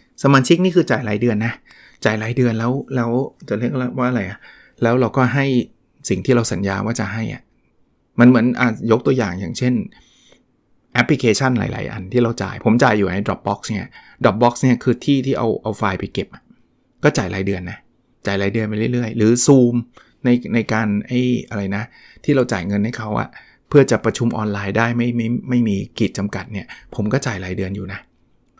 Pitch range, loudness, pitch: 105-125 Hz, -18 LUFS, 115 Hz